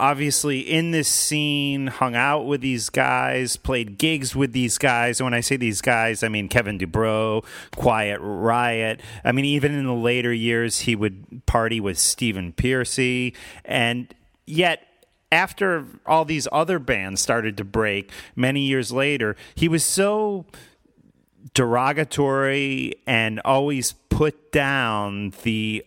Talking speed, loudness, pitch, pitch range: 140 wpm, -21 LUFS, 125 Hz, 110-140 Hz